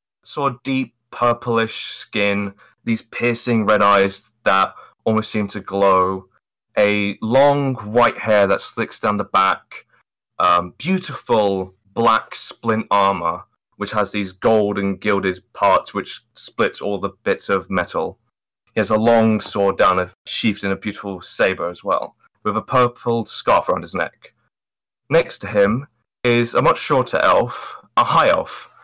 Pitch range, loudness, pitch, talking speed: 100-120 Hz, -19 LUFS, 105 Hz, 155 wpm